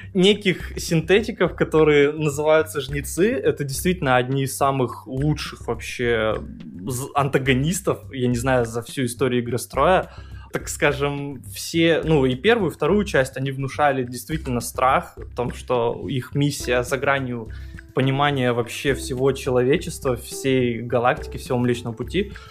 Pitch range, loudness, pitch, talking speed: 125-150 Hz, -22 LUFS, 135 Hz, 135 wpm